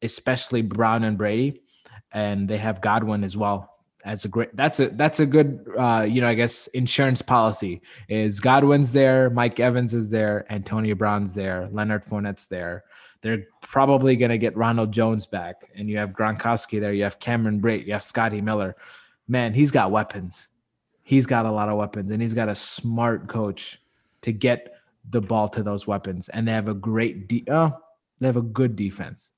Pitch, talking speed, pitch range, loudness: 110 Hz, 190 wpm, 105-120 Hz, -23 LUFS